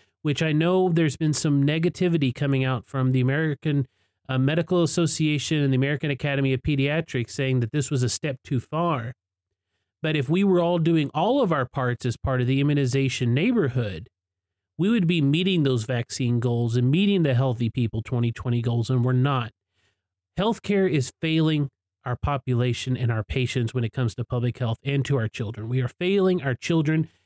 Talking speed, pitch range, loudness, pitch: 185 wpm, 120-155 Hz, -24 LUFS, 130 Hz